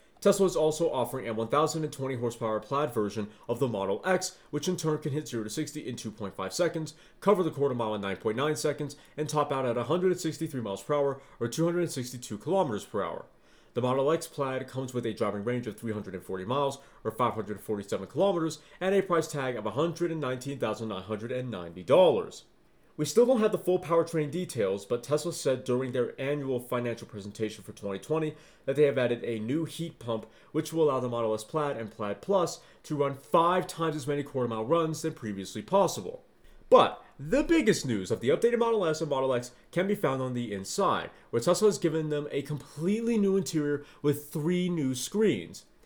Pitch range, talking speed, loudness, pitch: 120-160 Hz, 190 wpm, -30 LUFS, 140 Hz